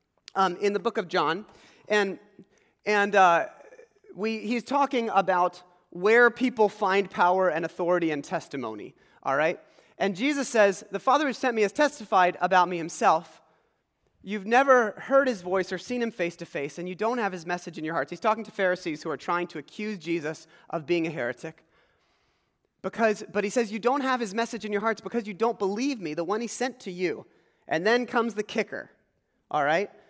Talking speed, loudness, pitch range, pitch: 200 wpm, -26 LUFS, 175-235 Hz, 205 Hz